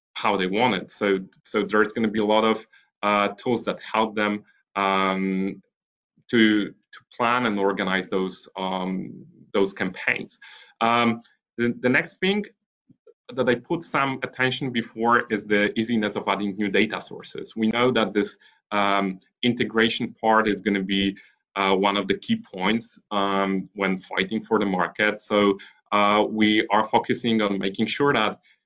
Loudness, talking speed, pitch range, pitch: -23 LUFS, 165 wpm, 100-115 Hz, 105 Hz